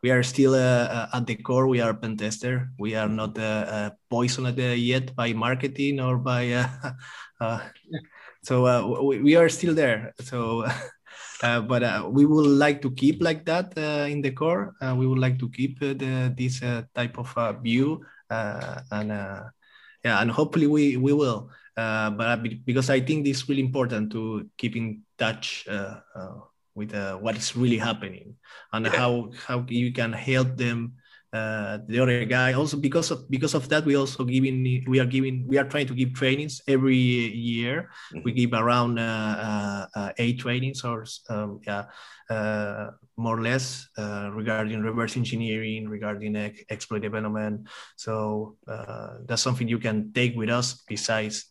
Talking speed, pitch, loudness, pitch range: 185 wpm, 120 Hz, -25 LUFS, 110-130 Hz